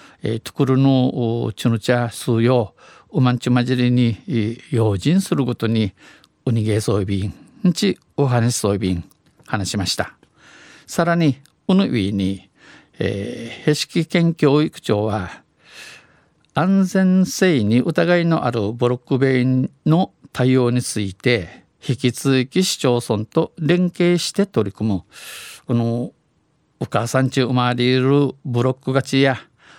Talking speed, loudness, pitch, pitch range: 215 characters per minute, -19 LUFS, 125 Hz, 115-150 Hz